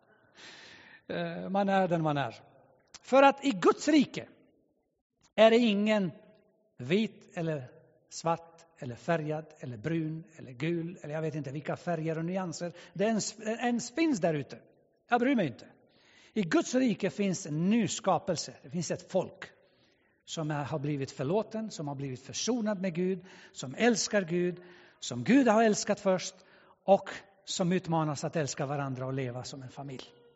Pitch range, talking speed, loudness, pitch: 150-205 Hz, 155 wpm, -30 LUFS, 175 Hz